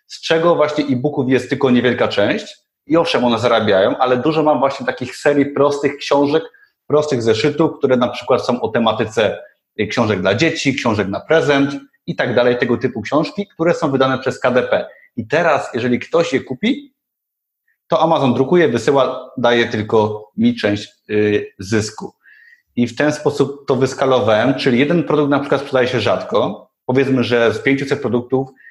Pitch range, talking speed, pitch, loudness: 125-155 Hz, 165 wpm, 135 Hz, -16 LUFS